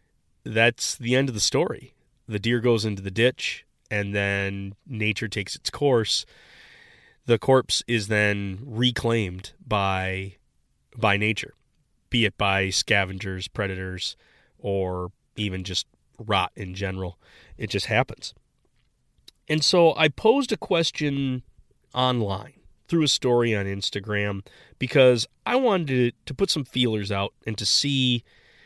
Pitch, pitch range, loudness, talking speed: 110 Hz, 100-125 Hz, -24 LUFS, 130 wpm